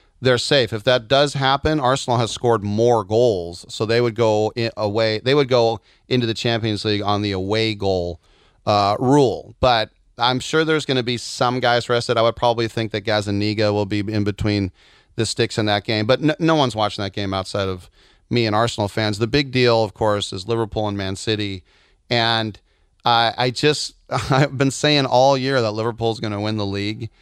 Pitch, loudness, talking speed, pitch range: 115 Hz, -19 LUFS, 205 wpm, 105-125 Hz